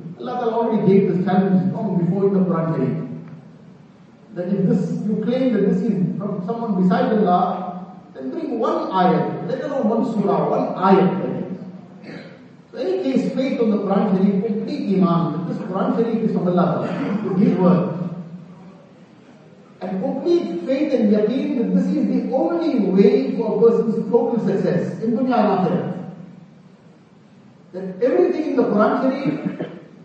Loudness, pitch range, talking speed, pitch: -19 LUFS, 185-225 Hz, 165 wpm, 195 Hz